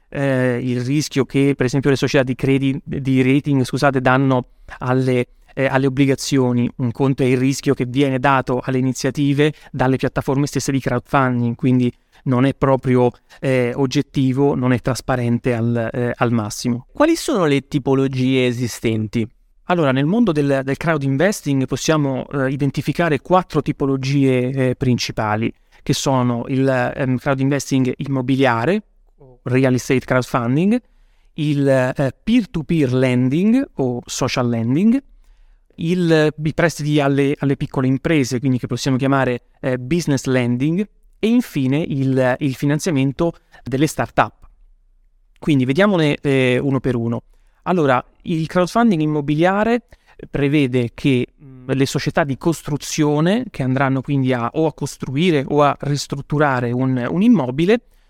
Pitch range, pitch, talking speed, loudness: 130-150 Hz, 135 Hz, 135 wpm, -18 LUFS